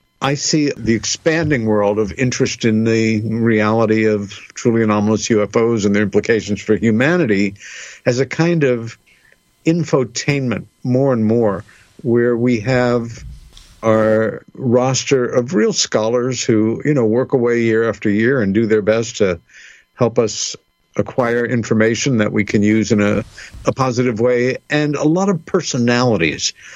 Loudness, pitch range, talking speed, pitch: -16 LUFS, 110-125 Hz, 150 wpm, 115 Hz